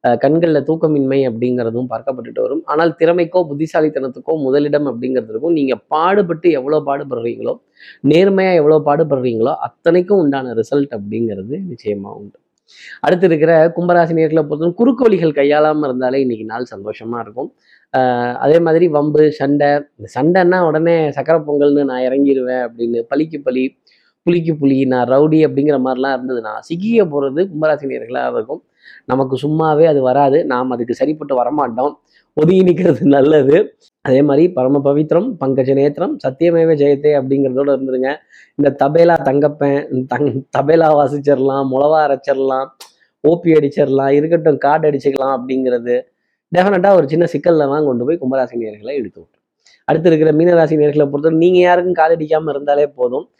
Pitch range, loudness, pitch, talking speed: 135-160 Hz, -14 LUFS, 145 Hz, 125 wpm